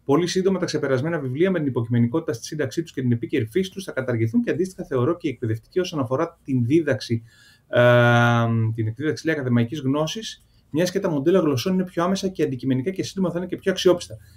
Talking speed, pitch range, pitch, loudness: 210 wpm, 120-175 Hz, 145 Hz, -23 LUFS